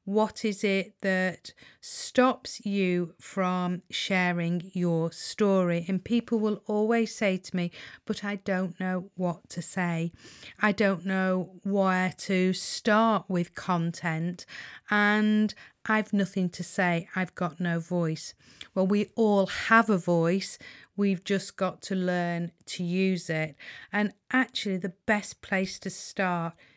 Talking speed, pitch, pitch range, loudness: 140 wpm, 190 Hz, 175-205 Hz, -28 LUFS